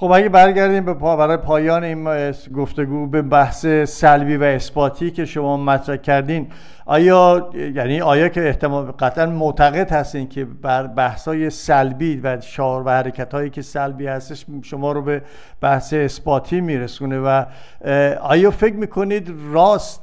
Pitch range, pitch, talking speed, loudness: 135-165 Hz, 145 Hz, 145 wpm, -17 LUFS